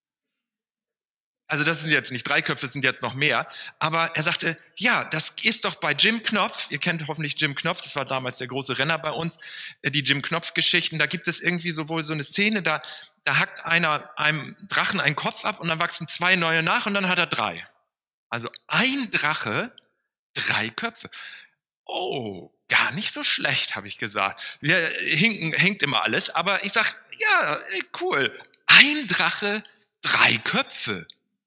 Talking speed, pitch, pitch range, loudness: 180 wpm, 165 Hz, 150-205 Hz, -21 LUFS